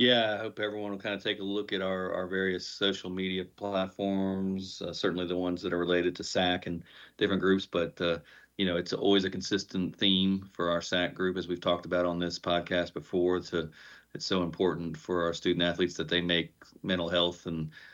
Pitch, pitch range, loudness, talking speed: 90 Hz, 85-95 Hz, -30 LUFS, 215 wpm